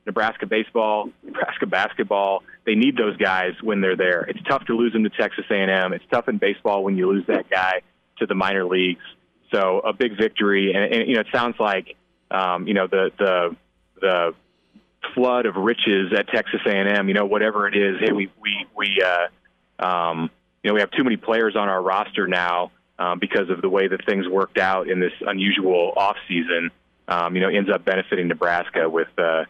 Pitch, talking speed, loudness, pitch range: 95 Hz, 205 wpm, -21 LUFS, 90-105 Hz